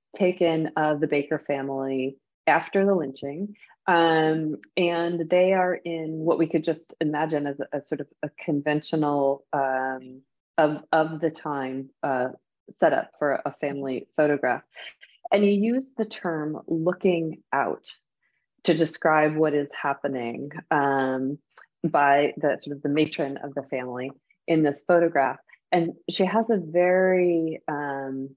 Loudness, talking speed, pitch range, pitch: -25 LUFS, 145 wpm, 140-170 Hz, 155 Hz